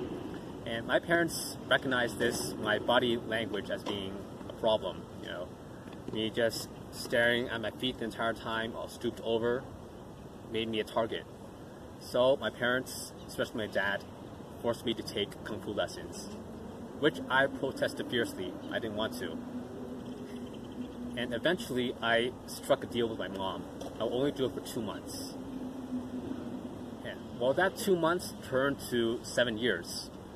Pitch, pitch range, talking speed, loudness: 120 Hz, 115-130 Hz, 150 wpm, -33 LUFS